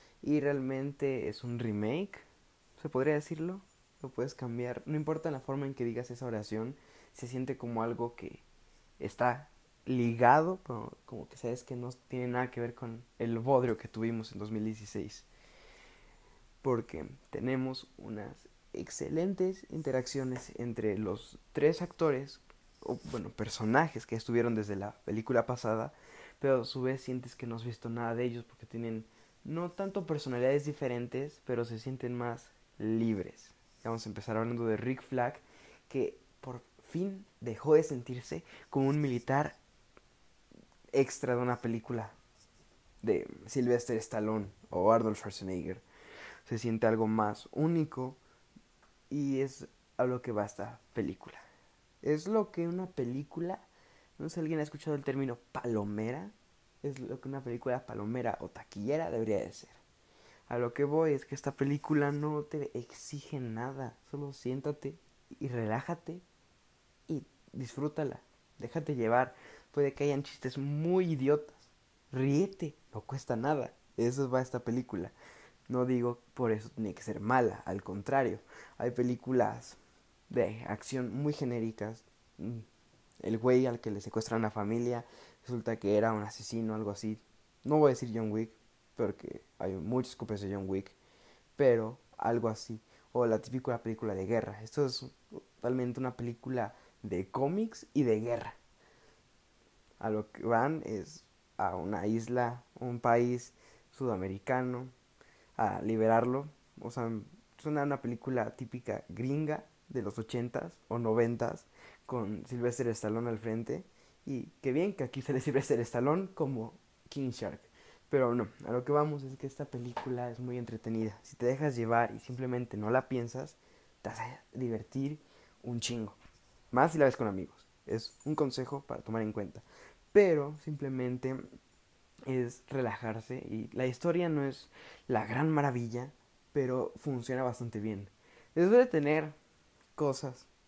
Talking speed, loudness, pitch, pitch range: 150 wpm, -35 LUFS, 125 Hz, 115-140 Hz